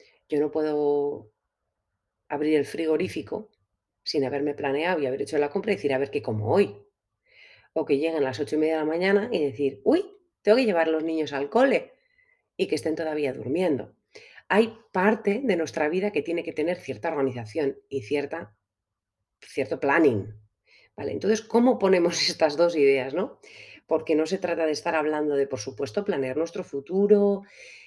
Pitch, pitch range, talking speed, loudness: 155 Hz, 140-195 Hz, 180 wpm, -25 LUFS